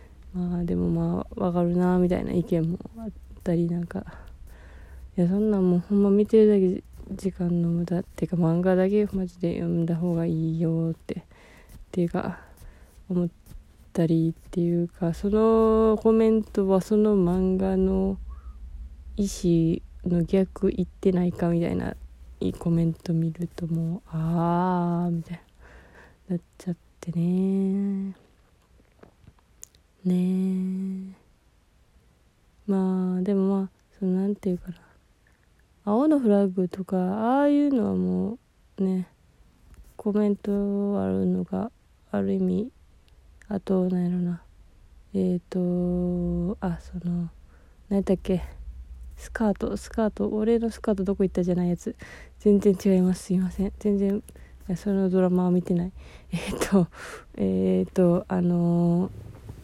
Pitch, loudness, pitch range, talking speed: 180 Hz, -25 LUFS, 165-195 Hz, 260 characters per minute